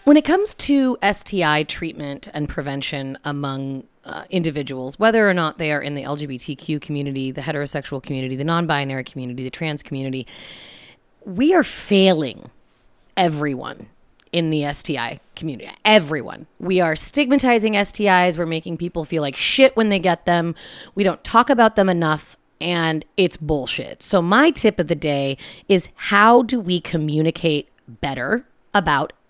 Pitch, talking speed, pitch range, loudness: 160 Hz, 150 wpm, 145-195 Hz, -20 LUFS